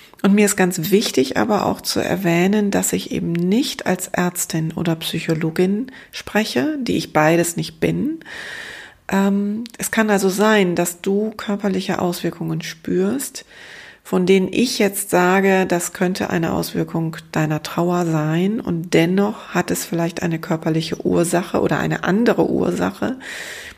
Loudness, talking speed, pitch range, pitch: -19 LUFS, 145 wpm, 170-200 Hz, 185 Hz